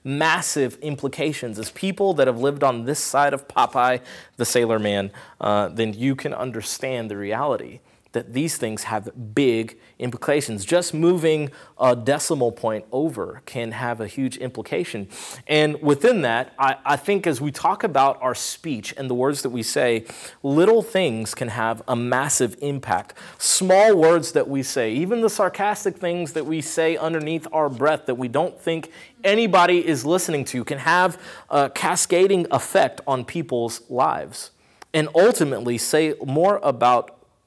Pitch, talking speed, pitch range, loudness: 140 Hz, 160 wpm, 120-160 Hz, -21 LUFS